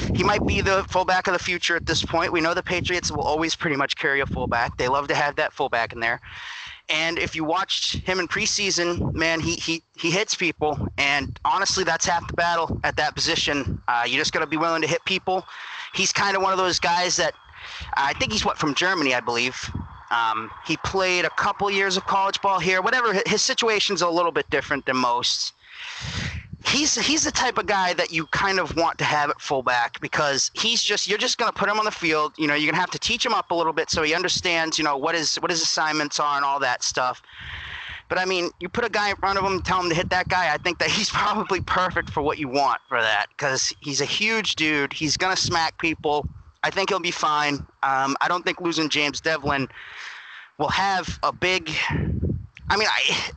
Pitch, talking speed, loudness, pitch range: 170 Hz, 235 wpm, -22 LUFS, 150-190 Hz